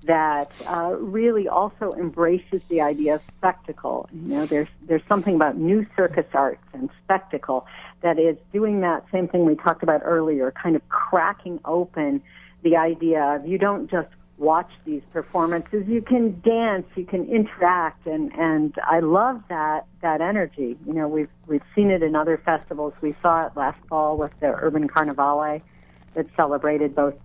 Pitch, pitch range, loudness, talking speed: 165 Hz, 155-185 Hz, -22 LUFS, 170 wpm